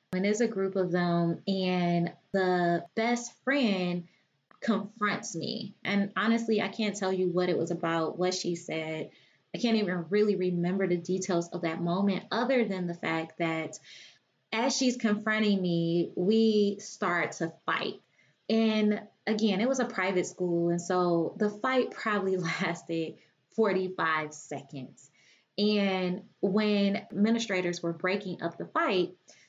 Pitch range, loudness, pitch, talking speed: 170-210 Hz, -29 LUFS, 185 Hz, 145 wpm